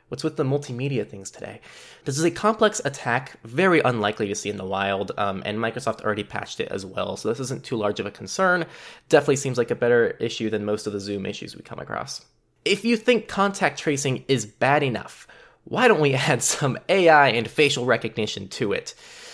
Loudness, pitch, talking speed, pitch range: -23 LUFS, 135 Hz, 210 wpm, 105-165 Hz